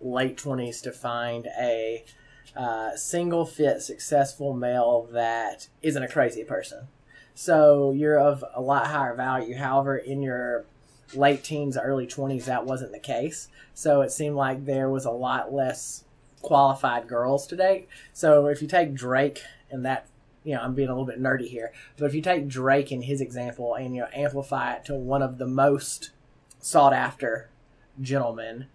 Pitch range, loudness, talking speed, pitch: 125-140 Hz, -25 LUFS, 175 wpm, 135 Hz